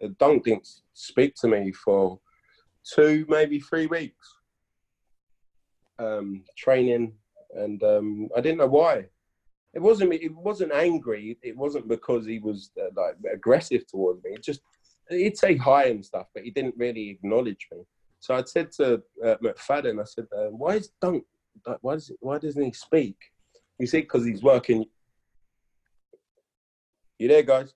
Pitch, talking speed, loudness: 145 Hz, 155 wpm, -25 LUFS